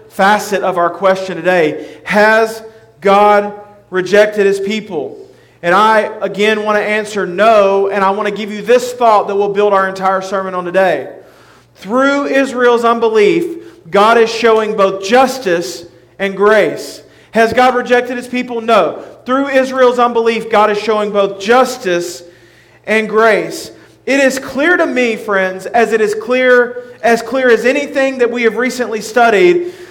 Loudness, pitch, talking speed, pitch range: -12 LUFS, 220 Hz, 155 wpm, 195-245 Hz